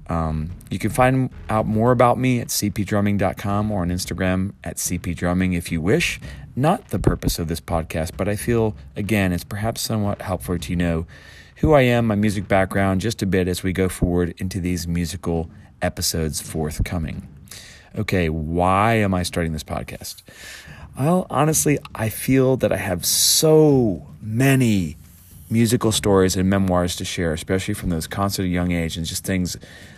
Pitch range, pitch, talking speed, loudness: 85-110 Hz, 95 Hz, 165 wpm, -21 LUFS